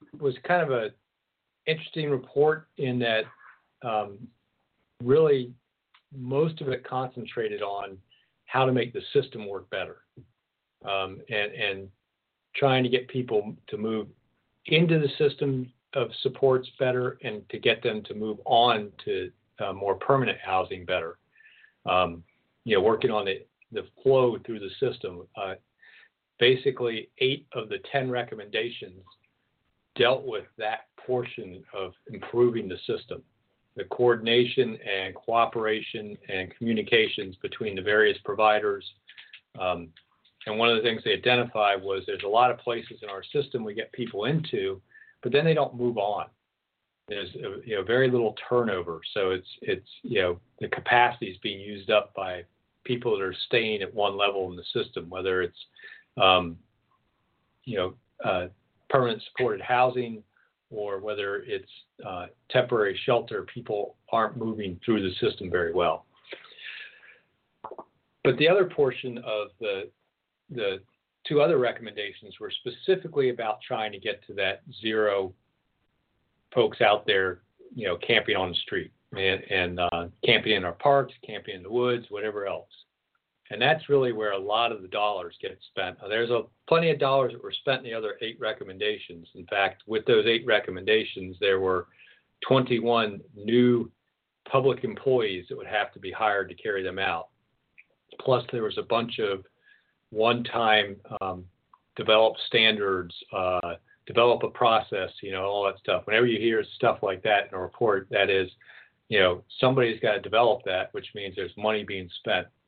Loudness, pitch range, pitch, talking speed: -26 LUFS, 100-150 Hz, 120 Hz, 155 wpm